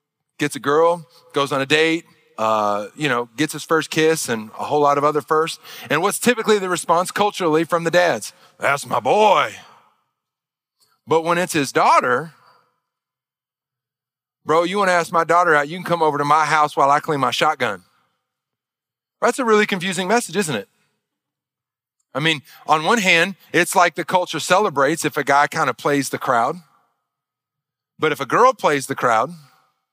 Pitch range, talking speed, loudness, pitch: 140-175 Hz, 180 wpm, -18 LUFS, 155 Hz